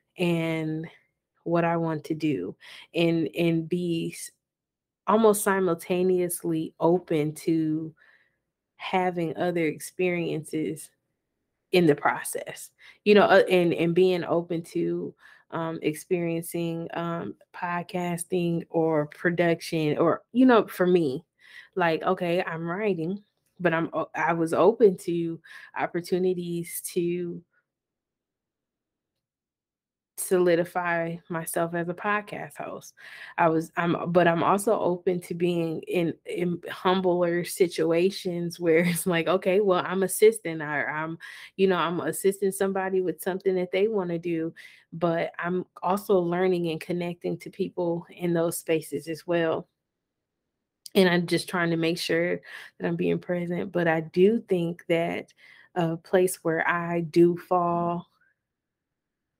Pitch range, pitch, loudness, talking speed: 165-185 Hz, 175 Hz, -26 LUFS, 125 wpm